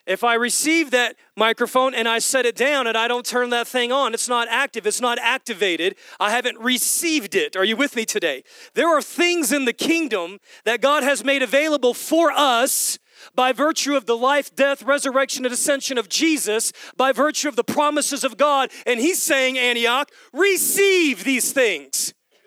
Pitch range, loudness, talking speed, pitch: 240-295 Hz, -19 LUFS, 185 wpm, 270 Hz